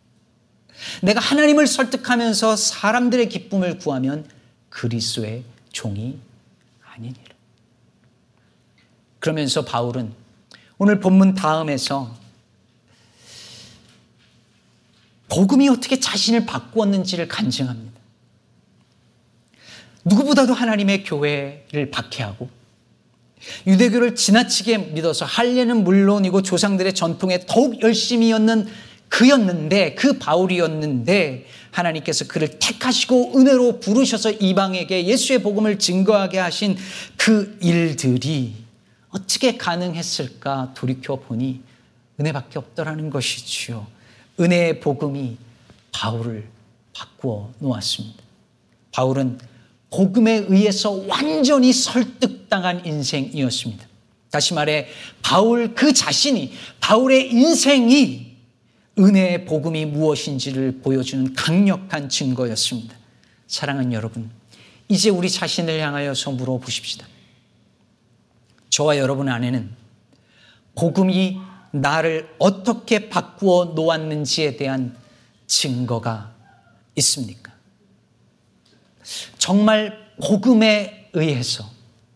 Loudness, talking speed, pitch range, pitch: -19 LUFS, 245 characters per minute, 125-210 Hz, 160 Hz